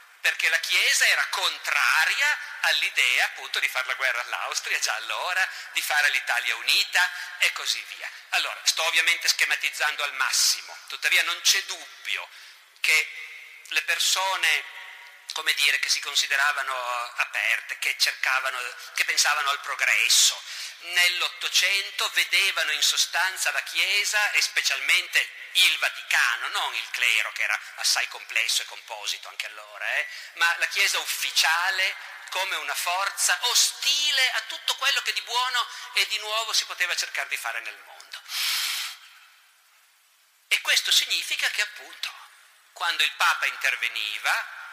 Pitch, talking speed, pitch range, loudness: 205 Hz, 135 wpm, 175-245 Hz, -23 LUFS